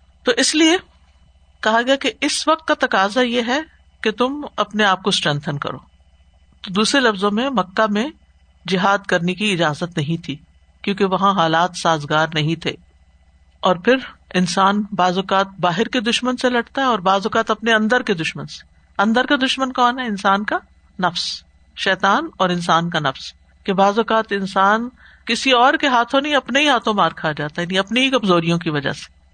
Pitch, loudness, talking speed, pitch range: 200 Hz, -18 LUFS, 185 wpm, 170-245 Hz